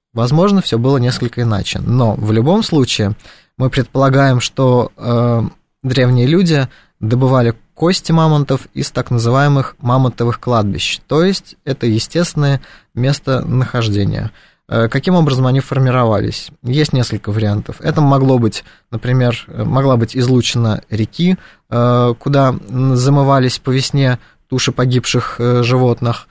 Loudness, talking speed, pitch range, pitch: -14 LUFS, 120 wpm, 120-140 Hz, 125 Hz